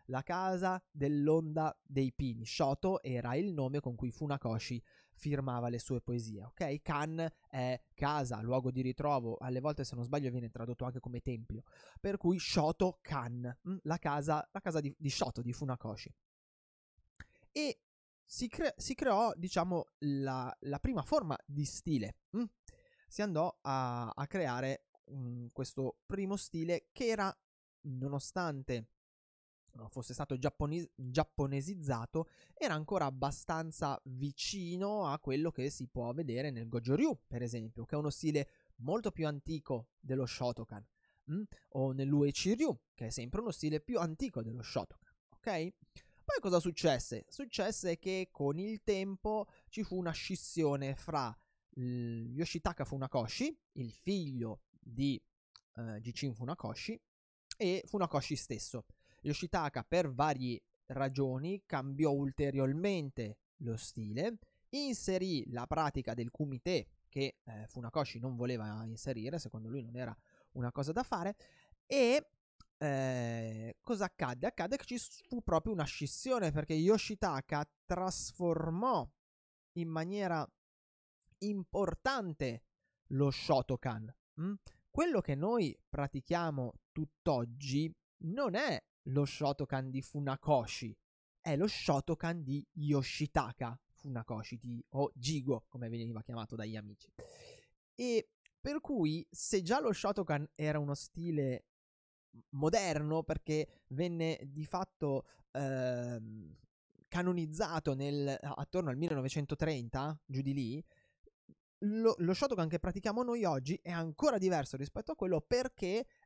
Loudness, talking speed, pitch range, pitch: -38 LUFS, 125 wpm, 125-175 Hz, 145 Hz